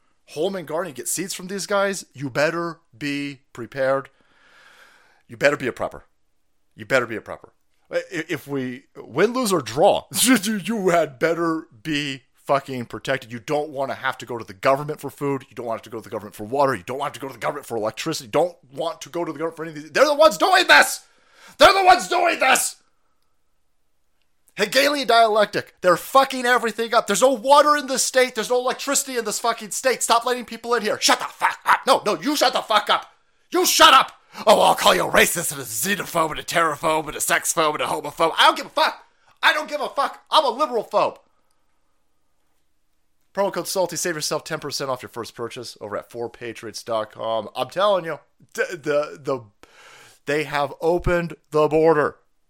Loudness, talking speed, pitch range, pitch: -20 LUFS, 210 wpm, 135-225 Hz, 160 Hz